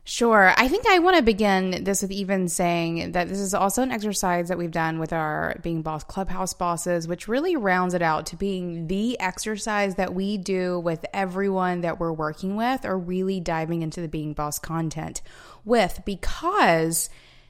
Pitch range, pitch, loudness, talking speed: 170-200 Hz, 185 Hz, -24 LUFS, 185 wpm